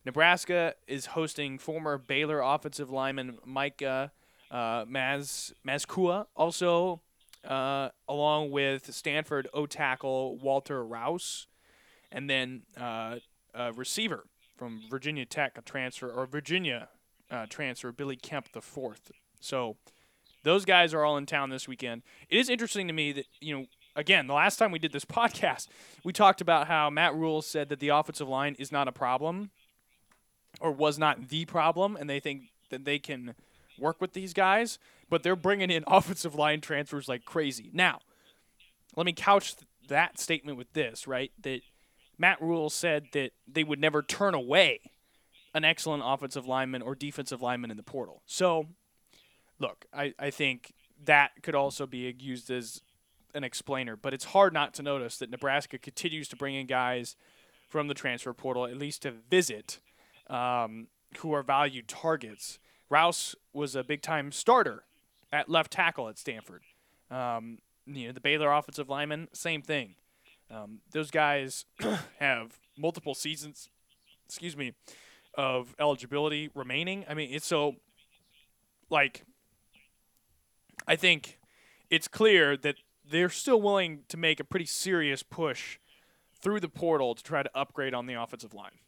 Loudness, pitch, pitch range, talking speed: -30 LUFS, 145 Hz, 130-160 Hz, 155 wpm